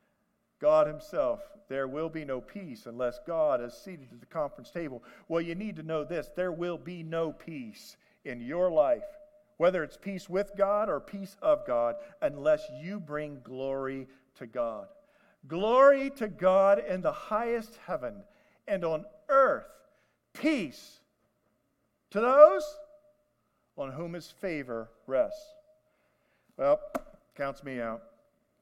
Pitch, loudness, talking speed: 205 Hz, -30 LUFS, 140 wpm